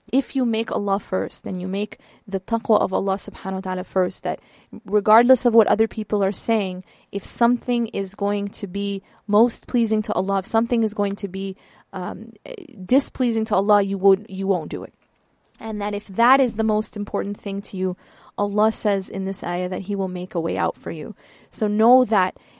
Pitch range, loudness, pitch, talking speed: 195-225 Hz, -22 LUFS, 205 Hz, 205 wpm